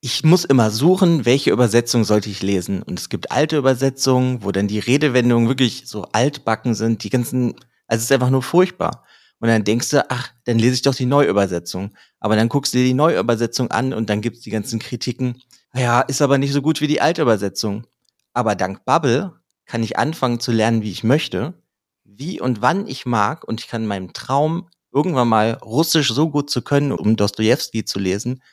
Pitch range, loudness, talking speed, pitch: 110-135 Hz, -19 LUFS, 205 wpm, 125 Hz